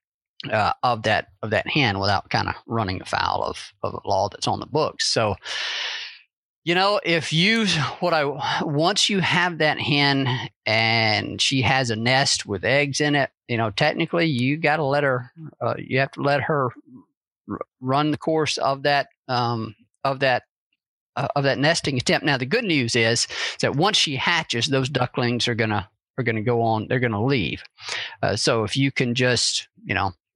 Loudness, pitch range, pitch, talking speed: -22 LUFS, 120-155 Hz, 135 Hz, 190 wpm